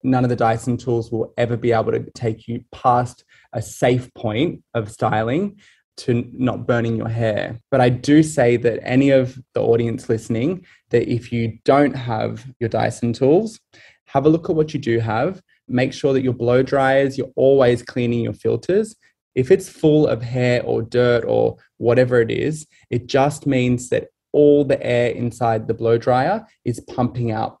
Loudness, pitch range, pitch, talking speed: -19 LUFS, 115-135 Hz, 125 Hz, 185 wpm